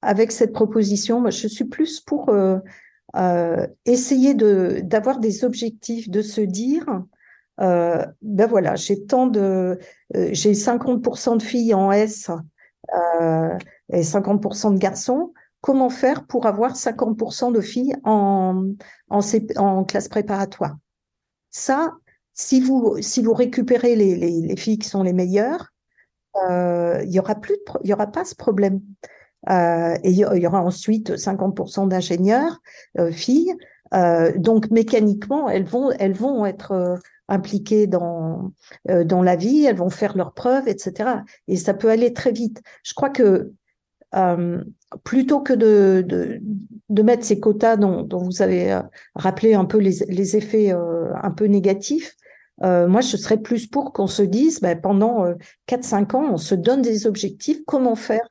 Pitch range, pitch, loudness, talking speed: 190-240 Hz, 210 Hz, -20 LUFS, 160 wpm